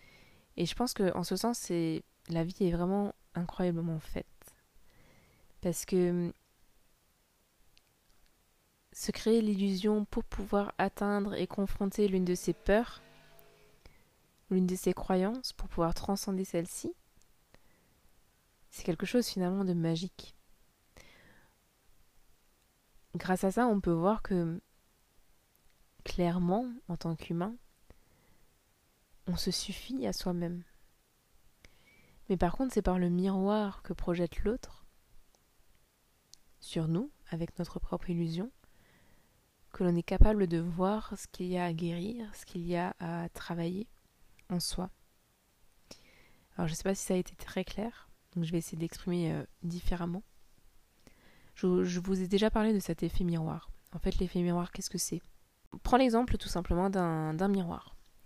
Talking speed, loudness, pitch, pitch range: 140 wpm, -33 LUFS, 185 Hz, 175-200 Hz